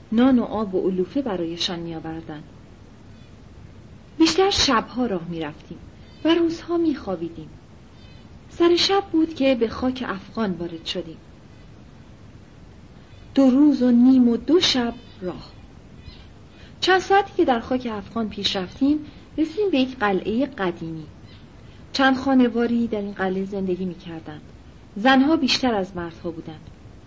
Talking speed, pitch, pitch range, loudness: 125 wpm, 225 Hz, 170-270 Hz, -21 LUFS